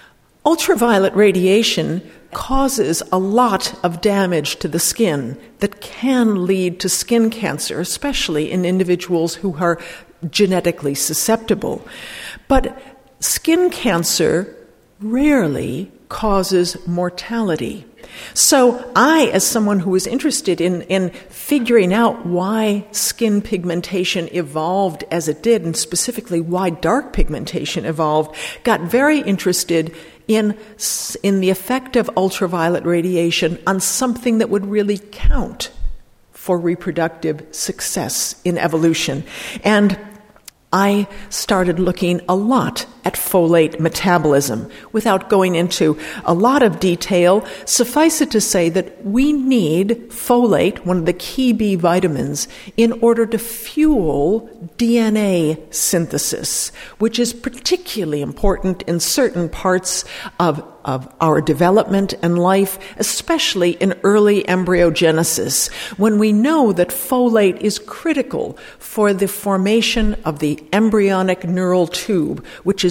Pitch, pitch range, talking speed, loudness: 195 Hz, 175-230 Hz, 120 wpm, -17 LUFS